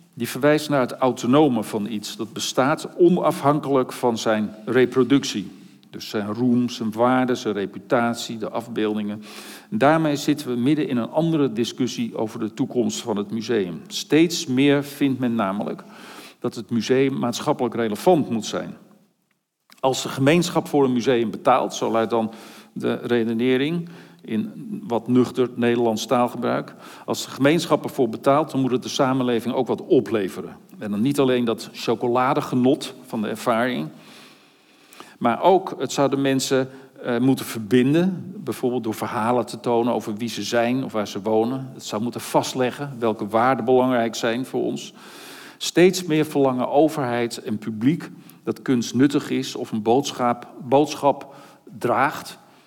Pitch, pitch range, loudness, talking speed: 125 Hz, 115-140 Hz, -22 LUFS, 155 wpm